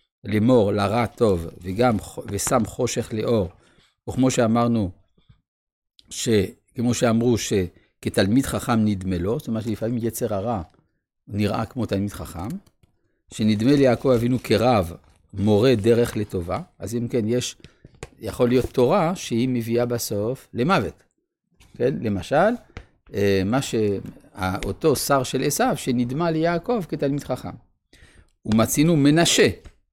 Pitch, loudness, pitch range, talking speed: 115 Hz, -22 LUFS, 100-125 Hz, 110 wpm